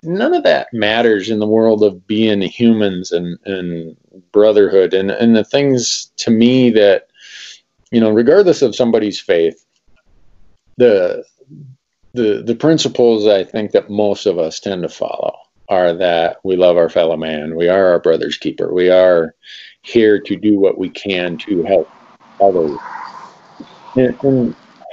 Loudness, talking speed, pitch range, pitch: -14 LUFS, 155 wpm, 95-135 Hz, 110 Hz